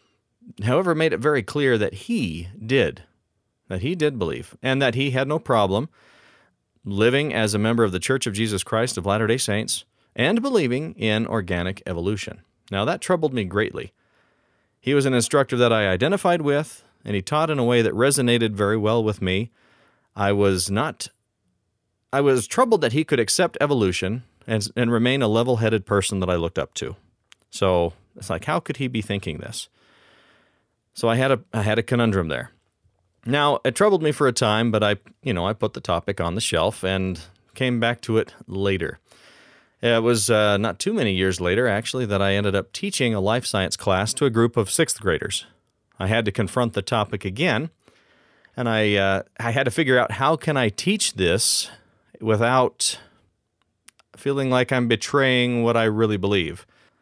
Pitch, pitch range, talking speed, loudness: 115 Hz, 100-130 Hz, 185 wpm, -22 LUFS